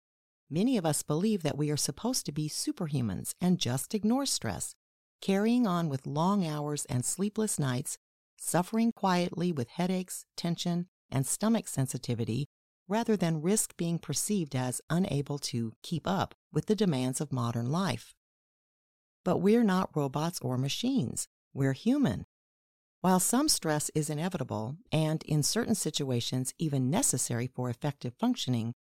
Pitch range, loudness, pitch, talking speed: 130-195 Hz, -31 LUFS, 155 Hz, 145 wpm